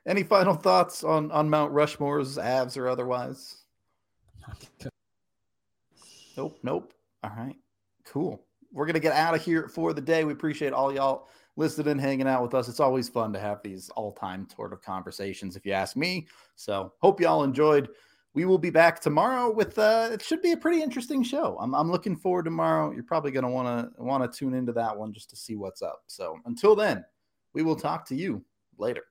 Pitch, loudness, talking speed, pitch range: 145 Hz, -27 LUFS, 200 wpm, 120-170 Hz